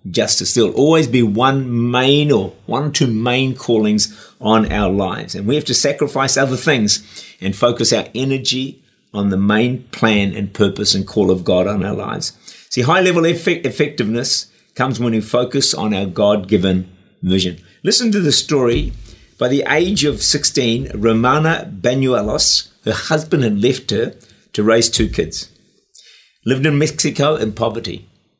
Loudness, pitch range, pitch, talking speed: -16 LUFS, 105-140 Hz, 120 Hz, 165 wpm